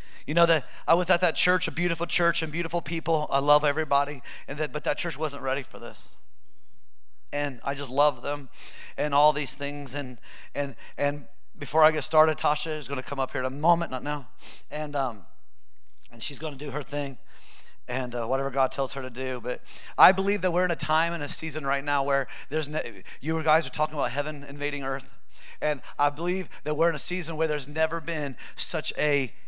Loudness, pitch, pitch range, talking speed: -27 LUFS, 145 Hz, 135-160 Hz, 220 wpm